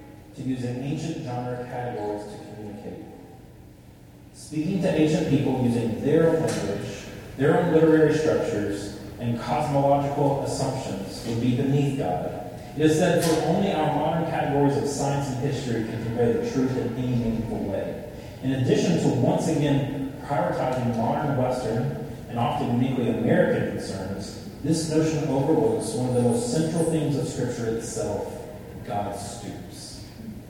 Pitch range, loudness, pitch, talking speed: 115-150 Hz, -25 LUFS, 130 Hz, 145 wpm